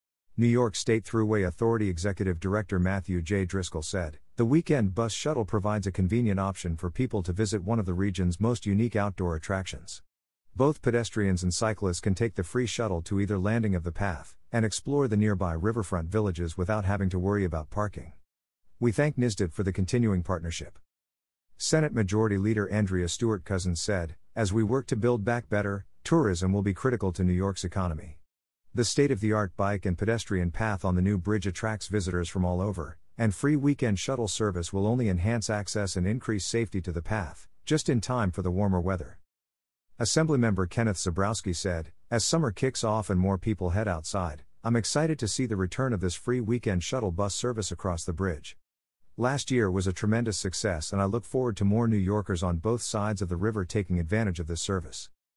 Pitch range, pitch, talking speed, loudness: 90-115 Hz, 100 Hz, 195 wpm, -28 LUFS